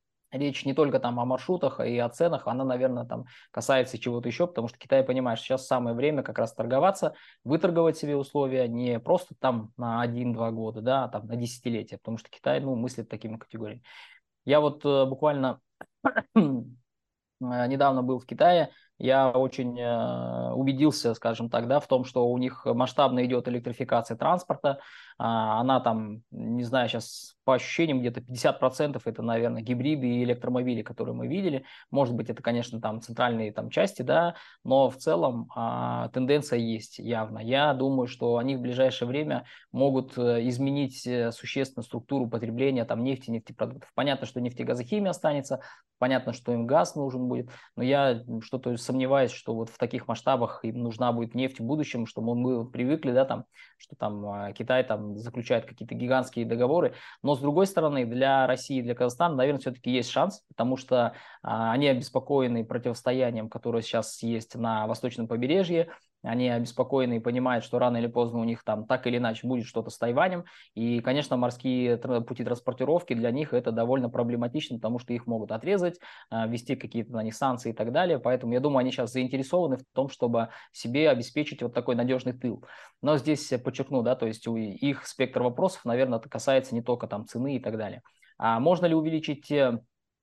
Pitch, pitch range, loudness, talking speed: 125 Hz, 115-135 Hz, -28 LUFS, 170 wpm